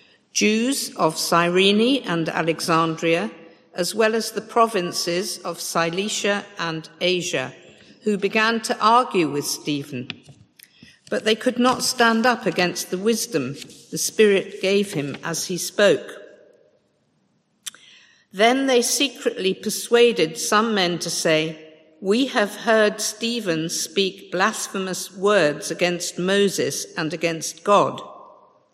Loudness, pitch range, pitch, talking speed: -21 LUFS, 170-220 Hz, 195 Hz, 115 wpm